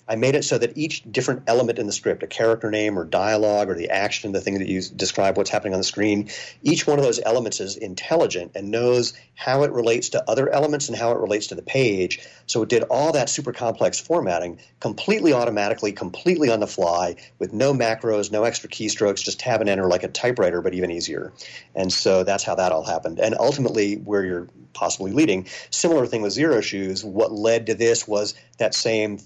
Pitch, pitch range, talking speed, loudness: 105 Hz, 95-115 Hz, 215 wpm, -22 LUFS